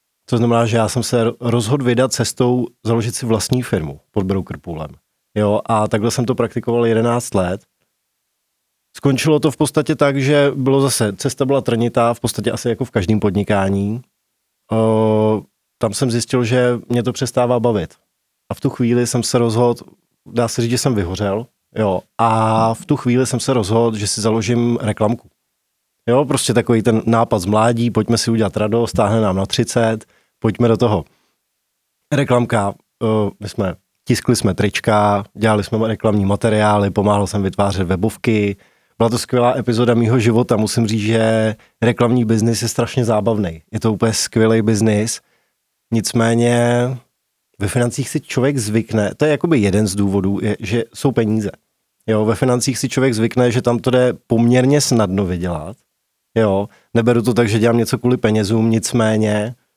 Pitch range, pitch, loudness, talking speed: 105-120 Hz, 115 Hz, -17 LUFS, 170 wpm